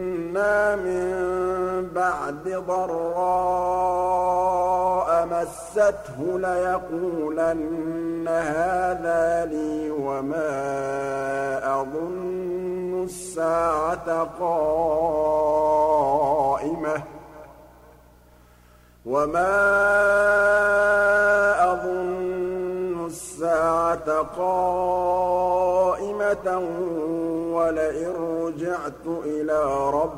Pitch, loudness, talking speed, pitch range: 175 Hz, -23 LUFS, 40 wpm, 160-185 Hz